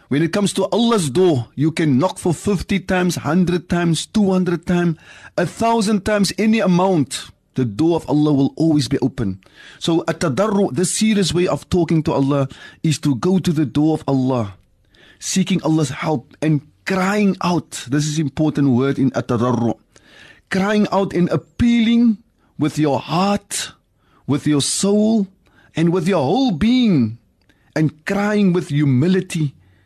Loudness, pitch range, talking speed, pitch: -18 LUFS, 140-190 Hz, 155 wpm, 165 Hz